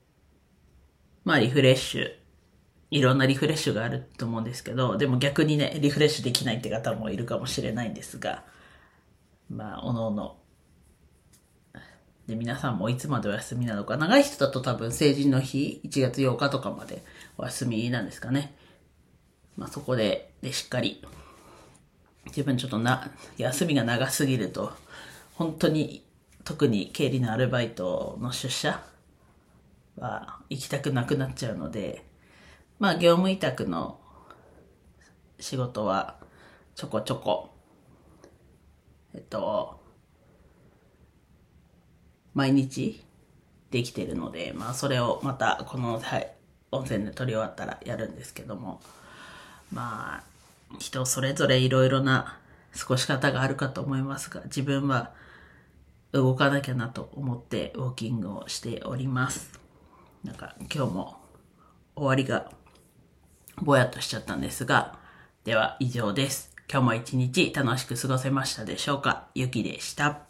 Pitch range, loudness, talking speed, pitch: 110-140 Hz, -28 LUFS, 275 characters per minute, 130 Hz